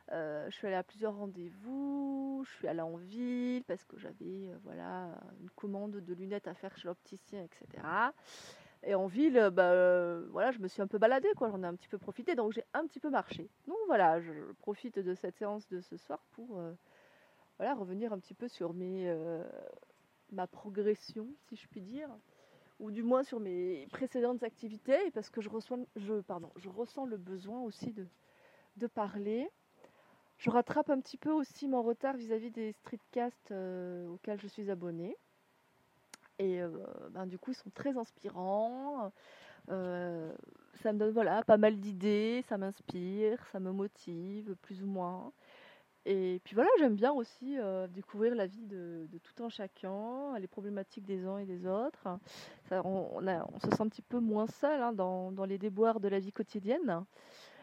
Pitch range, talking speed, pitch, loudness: 185-240 Hz, 190 wpm, 210 Hz, -36 LUFS